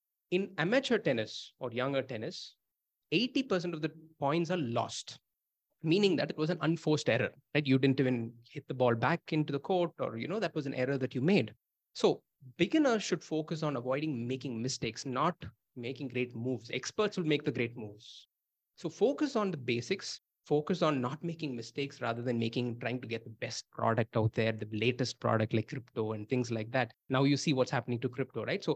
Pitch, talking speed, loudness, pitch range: 135 Hz, 205 wpm, -33 LUFS, 120-160 Hz